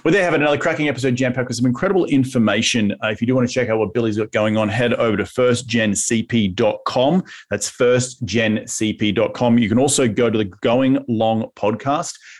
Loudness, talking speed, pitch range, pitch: -18 LUFS, 195 wpm, 110-125 Hz, 120 Hz